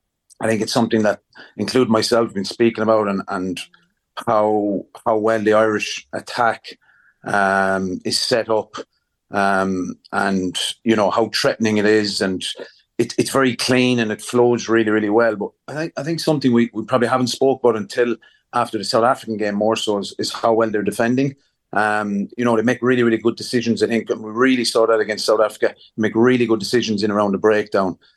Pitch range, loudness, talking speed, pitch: 105-120 Hz, -19 LUFS, 200 wpm, 110 Hz